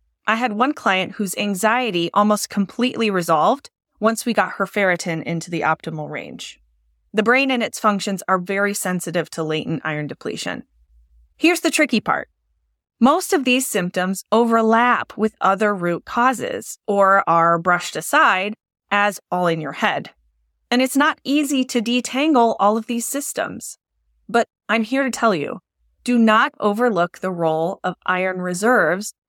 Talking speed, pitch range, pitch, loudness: 155 wpm, 175-240 Hz, 205 Hz, -19 LUFS